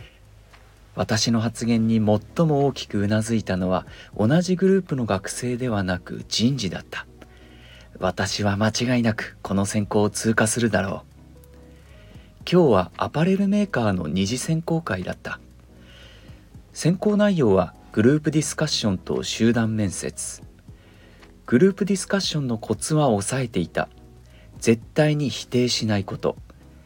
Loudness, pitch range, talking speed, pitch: -22 LUFS, 90-130 Hz, 285 characters per minute, 105 Hz